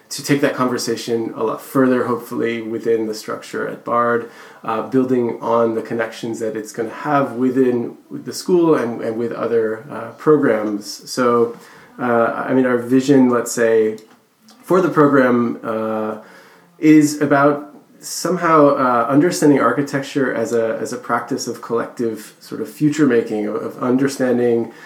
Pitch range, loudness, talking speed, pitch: 115-140 Hz, -18 LUFS, 155 wpm, 120 Hz